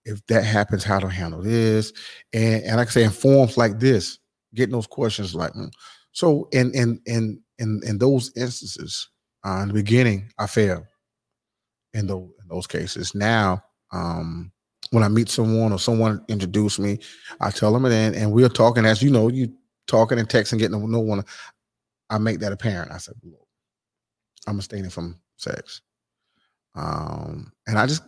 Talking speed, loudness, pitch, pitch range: 175 wpm, -21 LUFS, 110 Hz, 100-115 Hz